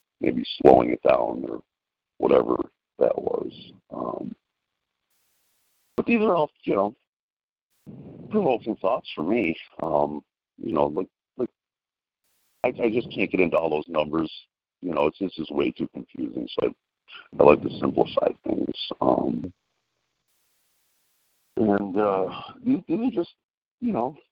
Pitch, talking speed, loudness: 170 Hz, 140 wpm, -25 LUFS